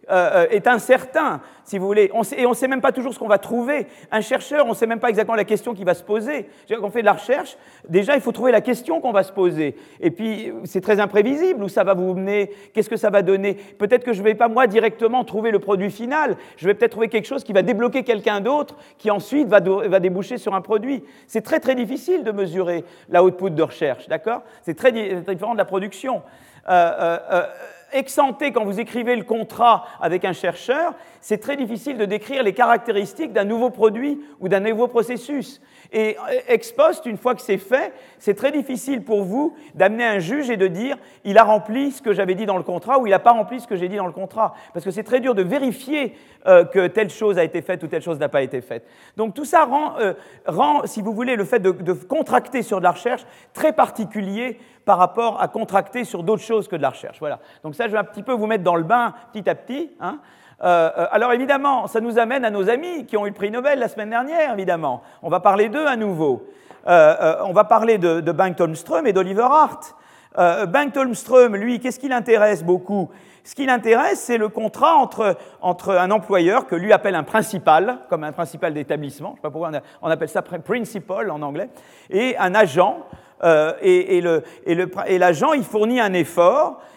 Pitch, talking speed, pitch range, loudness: 220 Hz, 235 wpm, 190-255 Hz, -19 LUFS